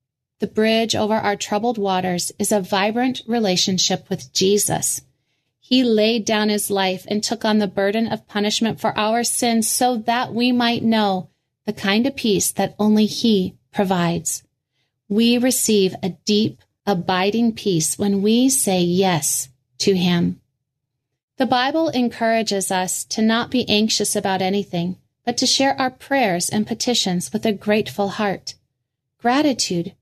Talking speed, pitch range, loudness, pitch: 150 wpm, 180-225 Hz, -19 LUFS, 205 Hz